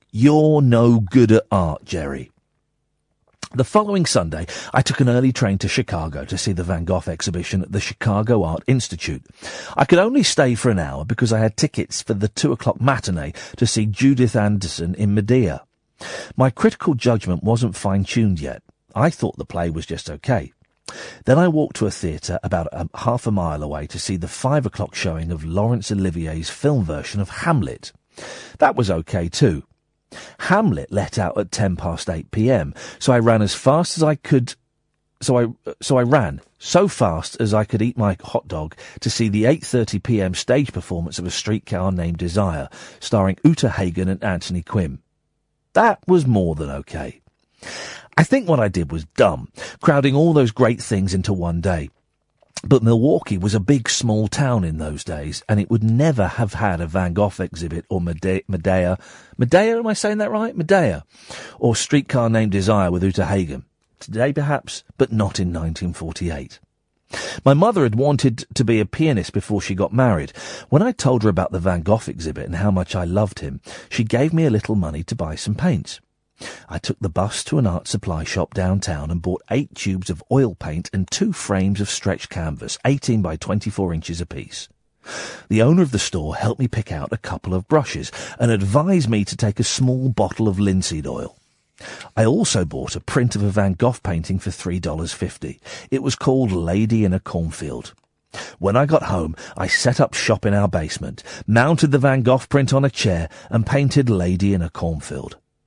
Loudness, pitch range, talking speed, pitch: -20 LUFS, 90-125 Hz, 190 wpm, 105 Hz